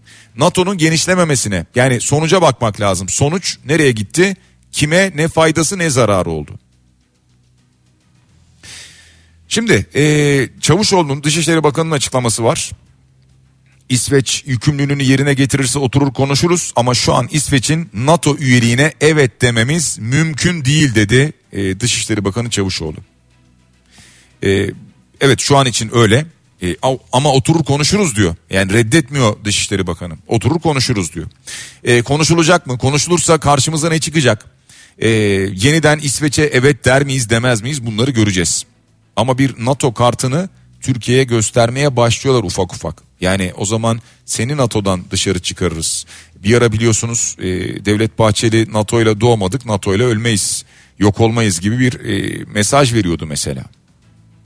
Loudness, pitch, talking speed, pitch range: -14 LUFS, 120 Hz, 125 wpm, 100-145 Hz